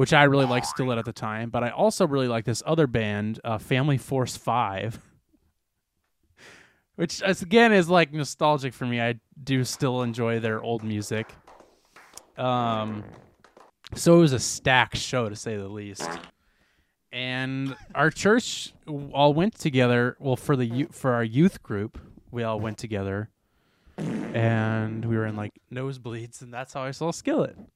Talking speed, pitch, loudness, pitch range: 160 wpm, 125 Hz, -25 LUFS, 110-140 Hz